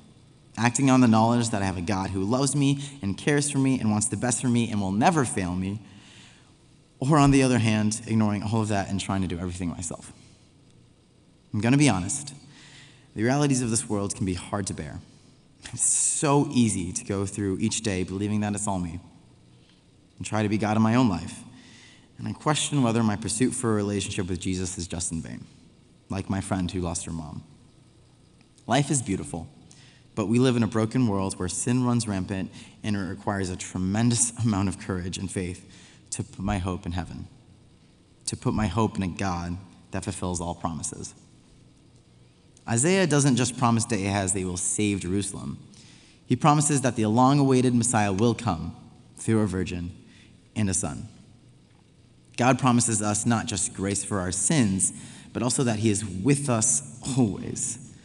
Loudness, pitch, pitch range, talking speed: -25 LUFS, 105 Hz, 95-125 Hz, 190 wpm